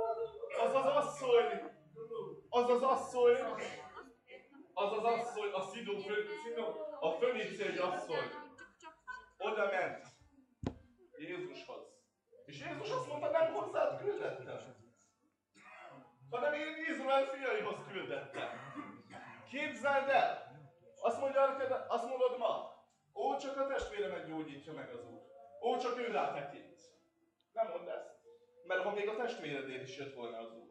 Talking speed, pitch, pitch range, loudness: 125 wpm, 265 Hz, 220-335 Hz, -37 LUFS